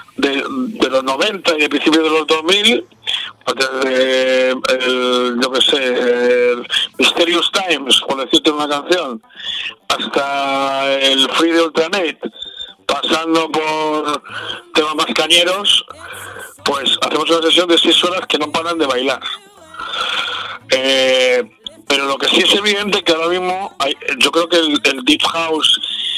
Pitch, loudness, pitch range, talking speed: 160 Hz, -14 LUFS, 135-185 Hz, 145 wpm